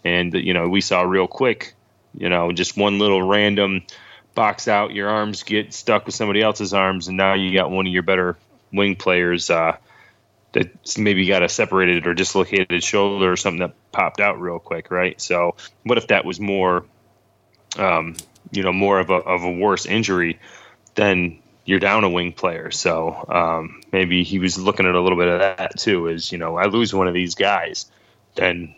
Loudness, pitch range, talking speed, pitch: -19 LUFS, 90-100 Hz, 200 wpm, 95 Hz